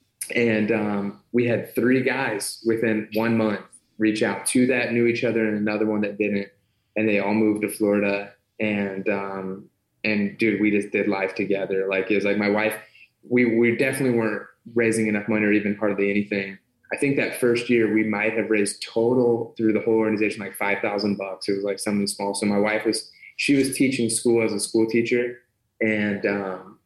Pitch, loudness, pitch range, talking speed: 110 Hz, -23 LUFS, 100-115 Hz, 200 wpm